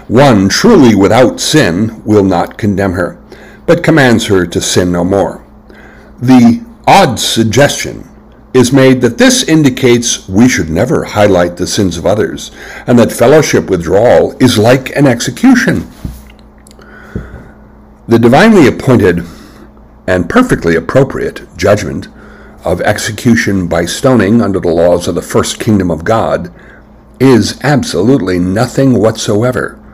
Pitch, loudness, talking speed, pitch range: 115 Hz, -9 LUFS, 125 wpm, 95-130 Hz